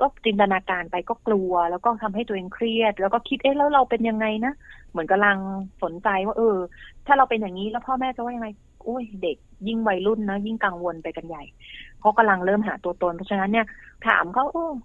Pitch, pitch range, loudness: 215 Hz, 190-235 Hz, -23 LUFS